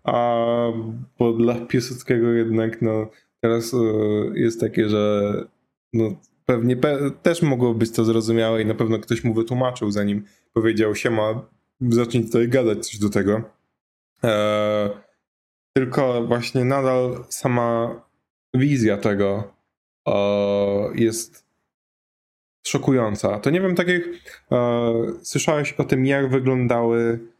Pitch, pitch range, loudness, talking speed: 115 Hz, 110-125 Hz, -21 LUFS, 125 wpm